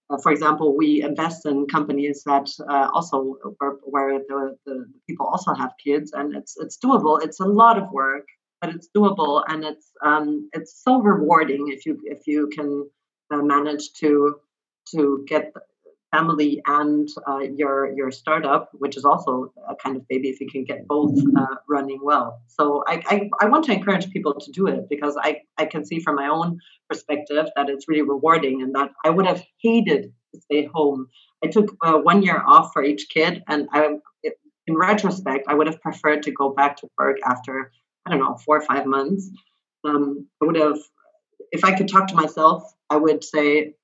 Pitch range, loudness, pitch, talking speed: 140-165 Hz, -21 LUFS, 150 Hz, 195 wpm